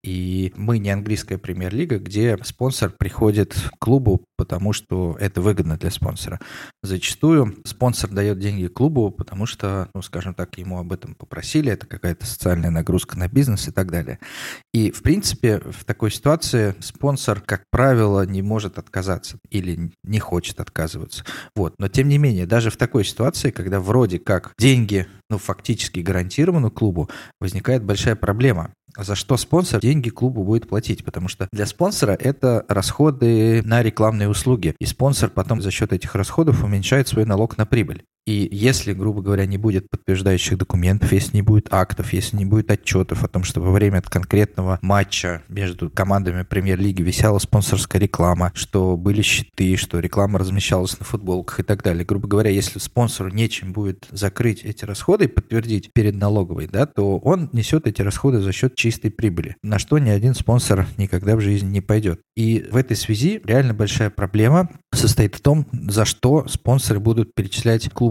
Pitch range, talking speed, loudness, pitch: 95-115 Hz, 170 wpm, -20 LUFS, 105 Hz